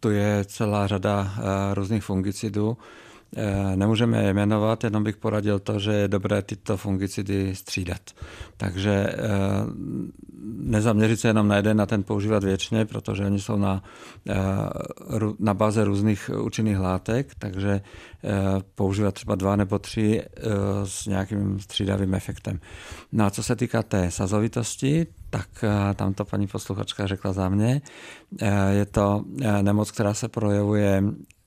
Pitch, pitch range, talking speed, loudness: 100 Hz, 100-110 Hz, 135 wpm, -25 LUFS